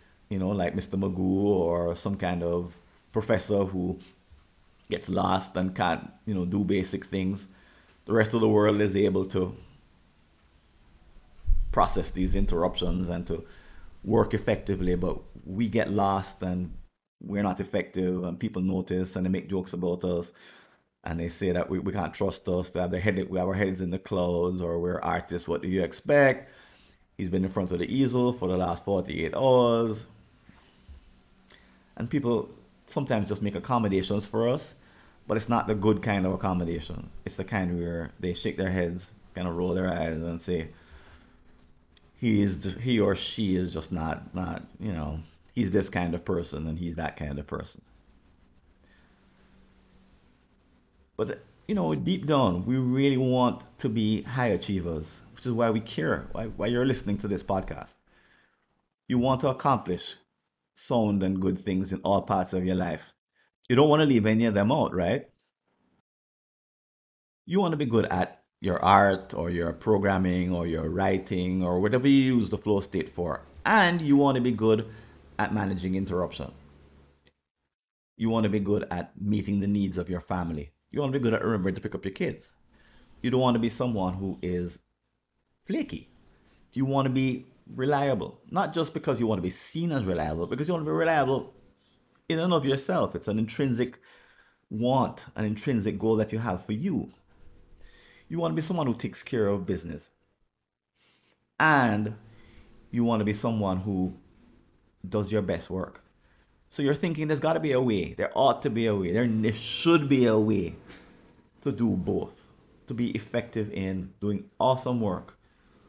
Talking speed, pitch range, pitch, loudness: 180 wpm, 90-115 Hz, 95 Hz, -28 LUFS